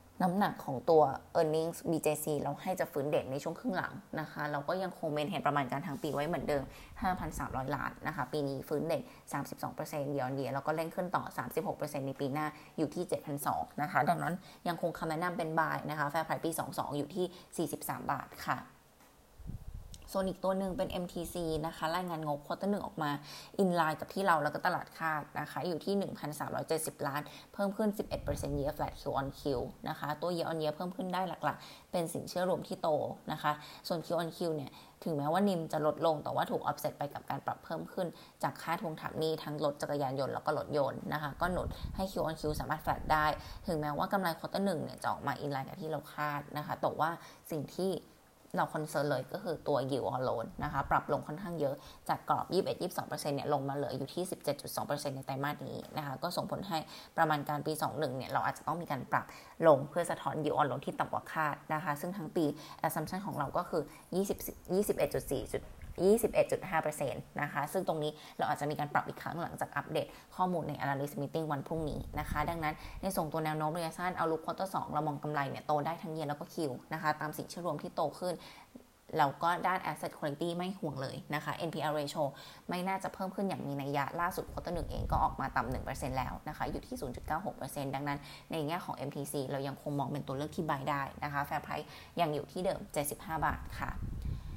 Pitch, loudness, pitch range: 155 Hz, -36 LUFS, 145-175 Hz